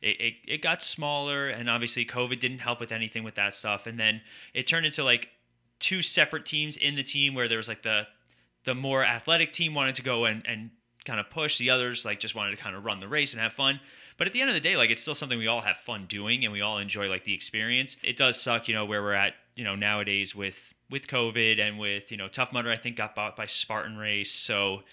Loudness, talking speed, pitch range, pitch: -27 LUFS, 260 wpm, 105-130 Hz, 115 Hz